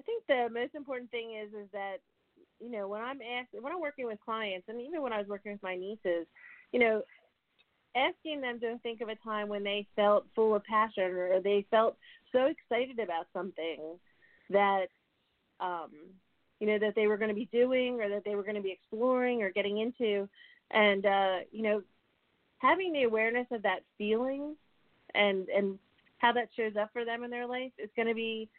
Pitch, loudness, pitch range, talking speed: 220 Hz, -32 LUFS, 205-245 Hz, 205 wpm